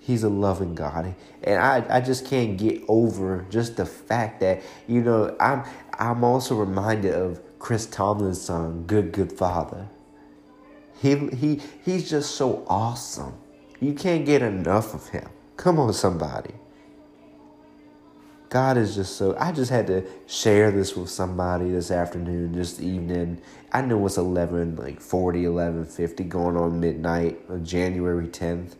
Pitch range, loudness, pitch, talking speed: 85-115 Hz, -24 LUFS, 95 Hz, 150 wpm